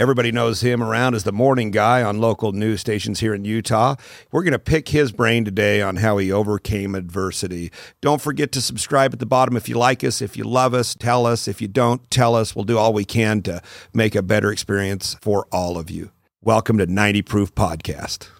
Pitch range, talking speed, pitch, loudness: 100-120 Hz, 220 wpm, 110 Hz, -19 LUFS